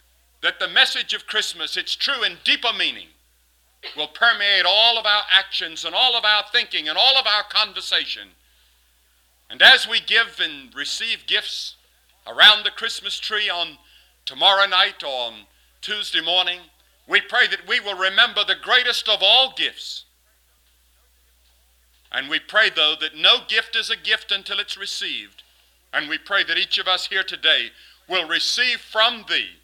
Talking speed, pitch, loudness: 165 wpm, 190 Hz, -18 LUFS